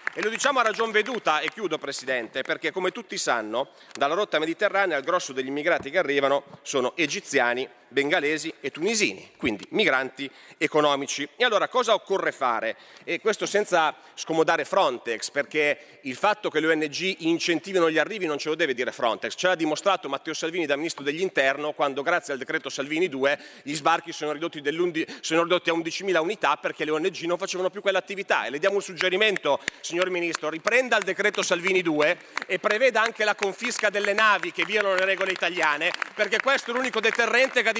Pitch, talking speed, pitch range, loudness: 170 Hz, 185 wpm, 150-200 Hz, -25 LUFS